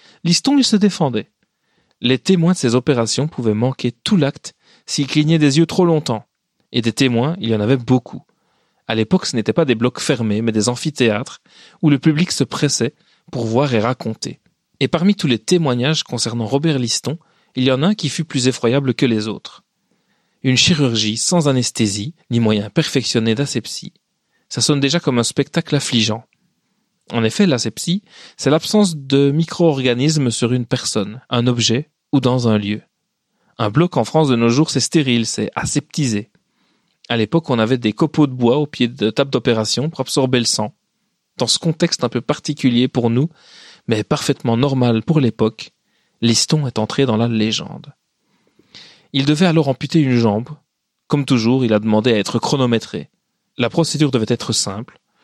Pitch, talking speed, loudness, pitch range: 130 Hz, 180 wpm, -17 LUFS, 115-155 Hz